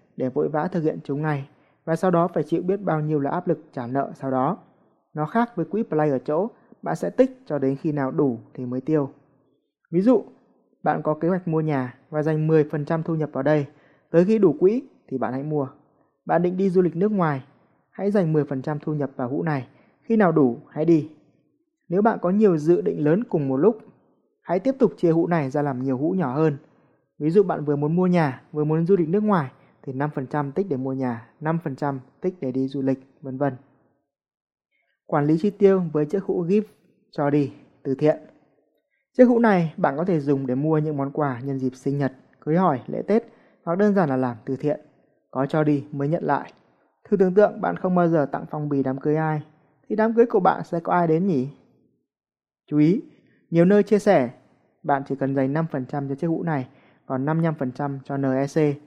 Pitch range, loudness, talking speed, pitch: 140-180 Hz, -23 LUFS, 225 wpm, 155 Hz